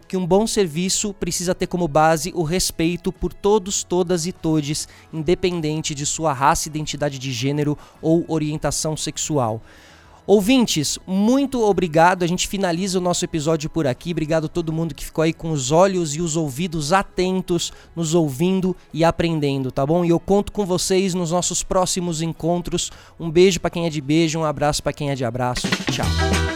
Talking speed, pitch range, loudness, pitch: 180 wpm, 155-185 Hz, -20 LUFS, 170 Hz